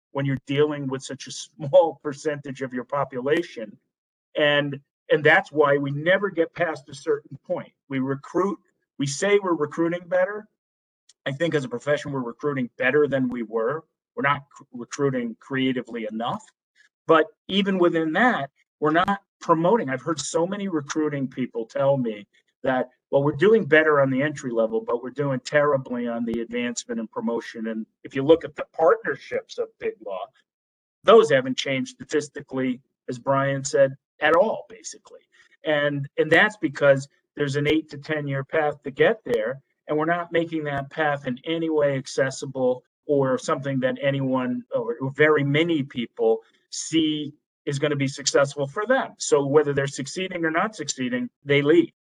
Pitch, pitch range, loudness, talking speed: 145 Hz, 130-165 Hz, -23 LUFS, 170 wpm